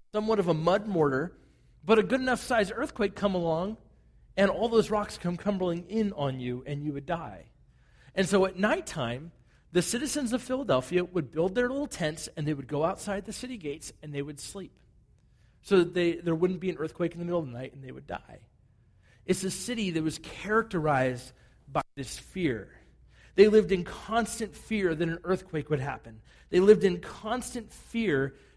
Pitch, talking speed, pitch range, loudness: 175 Hz, 195 wpm, 140-210 Hz, -29 LUFS